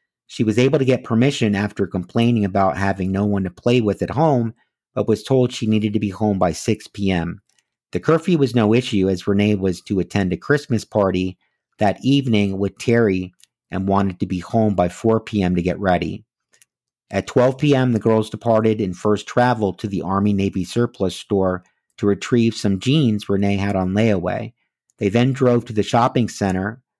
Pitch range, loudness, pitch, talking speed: 95-120 Hz, -19 LUFS, 105 Hz, 190 wpm